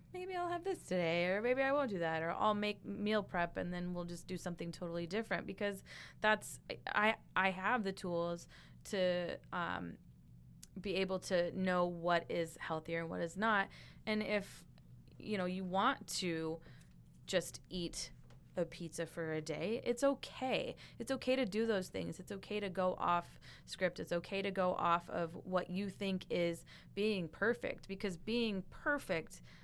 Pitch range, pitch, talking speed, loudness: 170-210 Hz, 185 Hz, 175 wpm, -38 LUFS